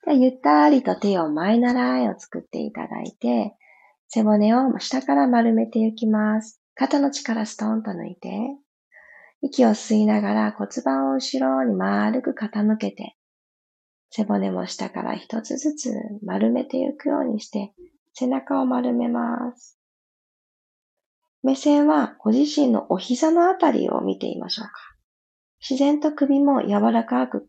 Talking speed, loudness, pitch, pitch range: 265 characters per minute, -22 LUFS, 230 Hz, 205-275 Hz